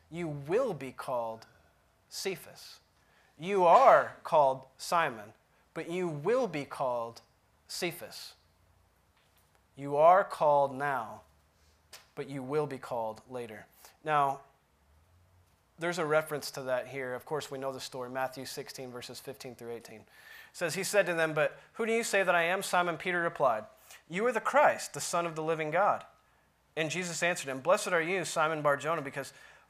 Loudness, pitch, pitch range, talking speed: -30 LUFS, 140 Hz, 115-165 Hz, 165 wpm